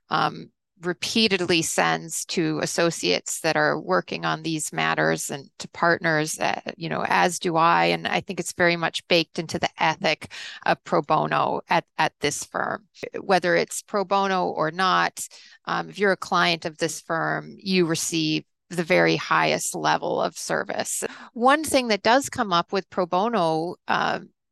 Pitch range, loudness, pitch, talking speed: 160-190 Hz, -23 LUFS, 170 Hz, 170 wpm